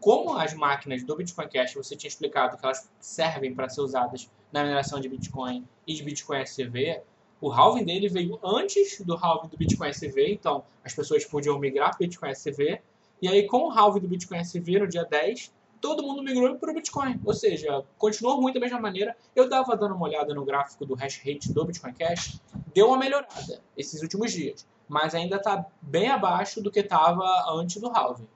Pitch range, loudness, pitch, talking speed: 145-220 Hz, -27 LUFS, 175 Hz, 205 wpm